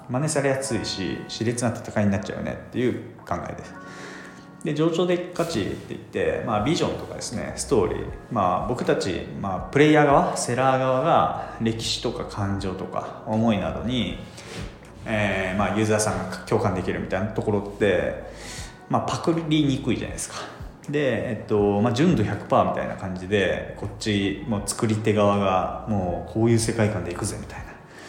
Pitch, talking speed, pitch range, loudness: 110 Hz, 365 characters per minute, 95-125 Hz, -24 LUFS